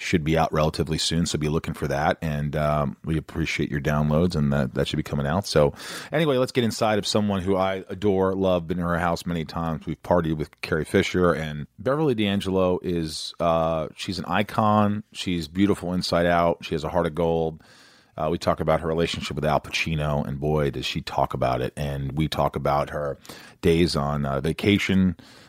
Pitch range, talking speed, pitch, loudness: 75-95 Hz, 205 wpm, 80 Hz, -24 LUFS